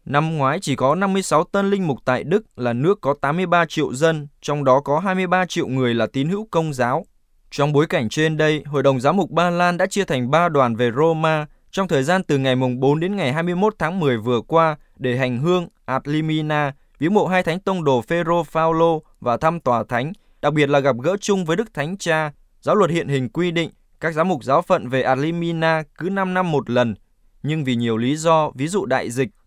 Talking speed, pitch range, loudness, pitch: 230 wpm, 135-175 Hz, -20 LUFS, 155 Hz